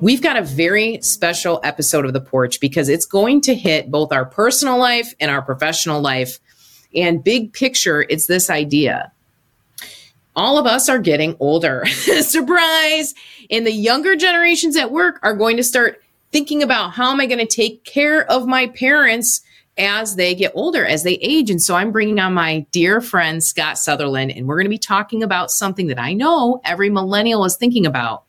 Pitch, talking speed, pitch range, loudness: 205 Hz, 190 wpm, 160-250 Hz, -16 LUFS